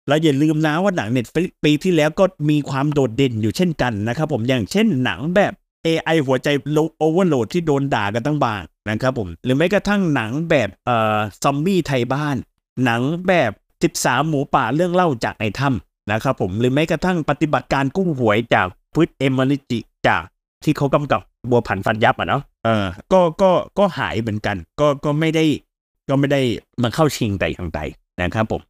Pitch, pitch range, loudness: 140 Hz, 115-160 Hz, -19 LUFS